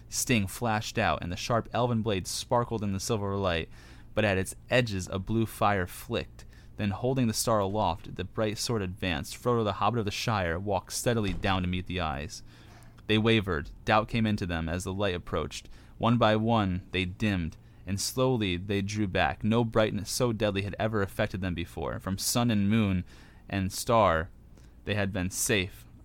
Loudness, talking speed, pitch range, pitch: -29 LUFS, 190 wpm, 95-115 Hz, 105 Hz